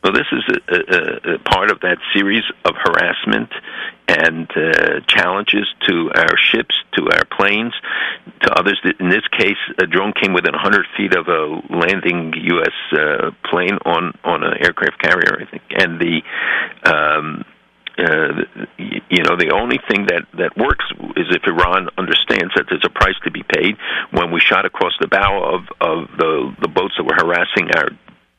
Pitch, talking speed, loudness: 115 Hz, 175 wpm, -15 LUFS